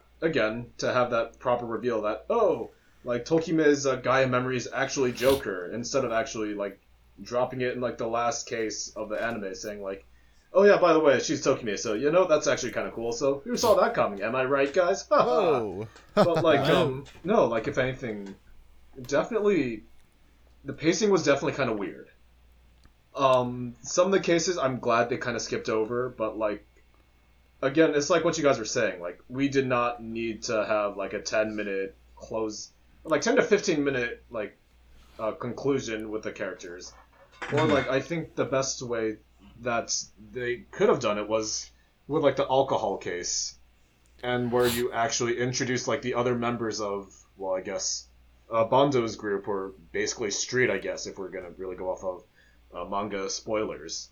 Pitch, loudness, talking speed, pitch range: 115 Hz, -27 LUFS, 185 wpm, 100-135 Hz